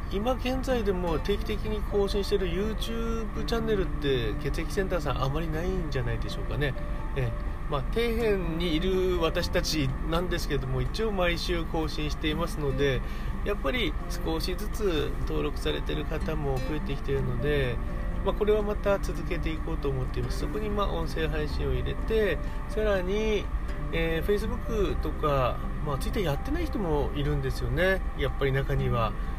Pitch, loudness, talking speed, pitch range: 165 Hz, -29 LUFS, 385 characters per minute, 135-200 Hz